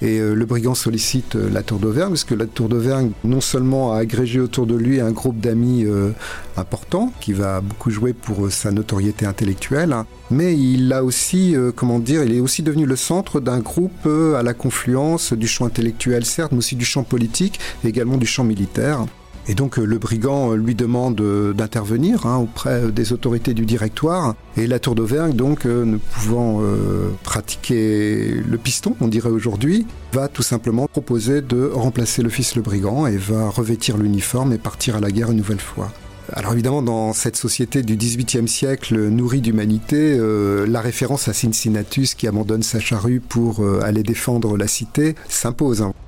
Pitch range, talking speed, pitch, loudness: 110-130 Hz, 180 wpm, 120 Hz, -19 LUFS